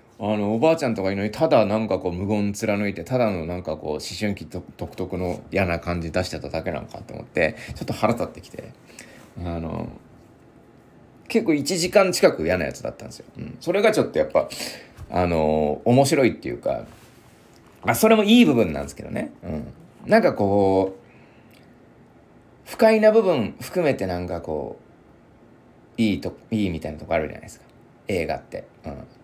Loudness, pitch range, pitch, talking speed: -22 LUFS, 85-125 Hz, 100 Hz, 345 characters per minute